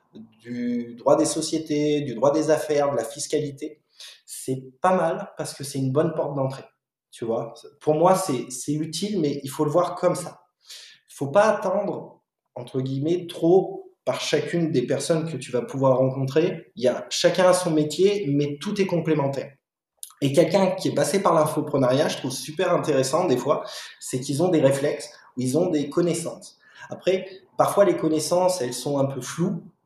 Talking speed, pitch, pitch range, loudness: 190 wpm, 155 Hz, 135-175 Hz, -23 LUFS